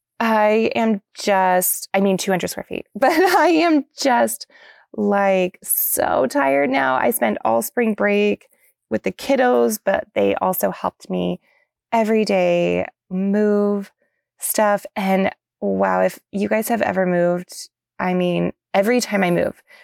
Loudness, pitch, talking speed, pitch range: -19 LUFS, 195 Hz, 140 wpm, 165-220 Hz